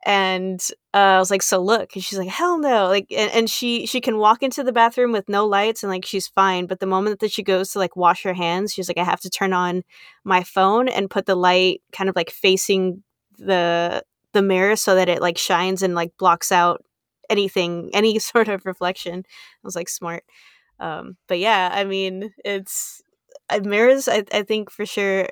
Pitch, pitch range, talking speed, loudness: 195 Hz, 185-210 Hz, 215 wpm, -20 LUFS